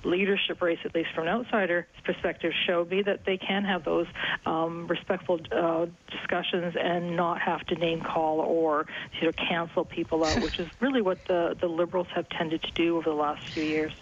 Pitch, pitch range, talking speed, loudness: 170 Hz, 165-180 Hz, 195 wpm, -28 LUFS